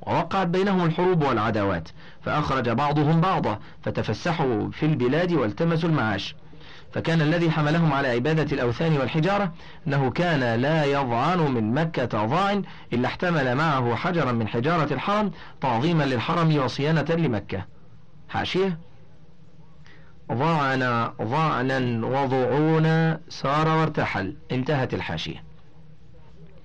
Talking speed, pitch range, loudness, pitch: 105 wpm, 125-165 Hz, -24 LUFS, 155 Hz